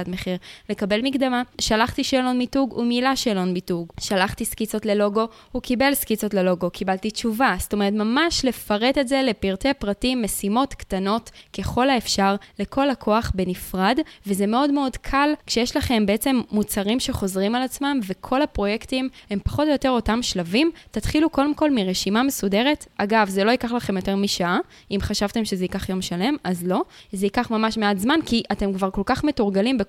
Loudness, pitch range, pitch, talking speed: -22 LUFS, 200-260 Hz, 220 Hz, 165 wpm